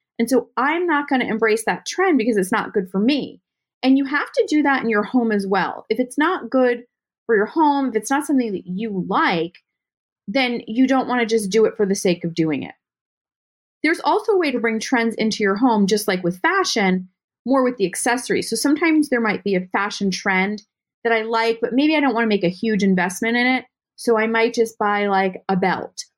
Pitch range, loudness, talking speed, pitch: 205-265 Hz, -19 LUFS, 230 wpm, 230 Hz